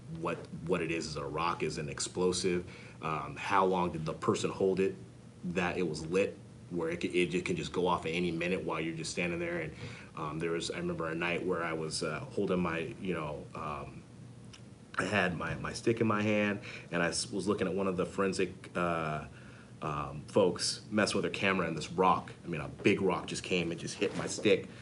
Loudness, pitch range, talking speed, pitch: -33 LUFS, 85-100 Hz, 225 wpm, 90 Hz